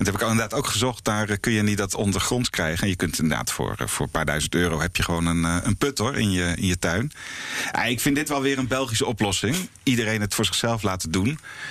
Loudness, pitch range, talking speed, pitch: -23 LUFS, 90-120 Hz, 245 wpm, 105 Hz